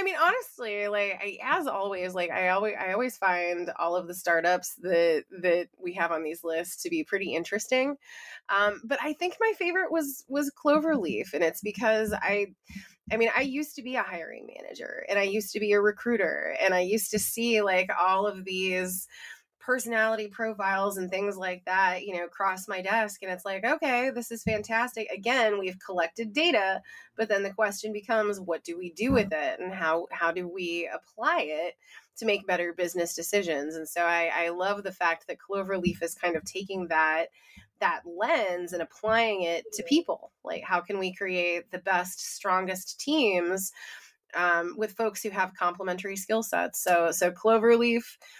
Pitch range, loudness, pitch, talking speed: 180-230 Hz, -28 LUFS, 200 Hz, 190 wpm